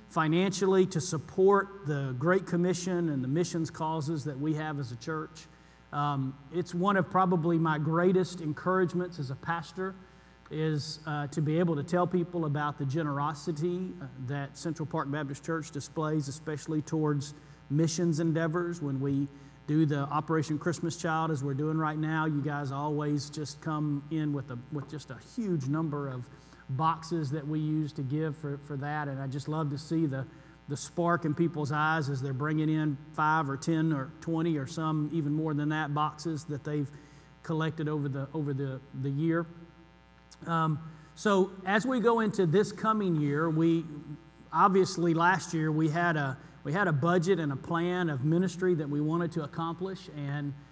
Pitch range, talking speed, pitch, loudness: 145-170 Hz, 180 wpm, 155 Hz, -31 LUFS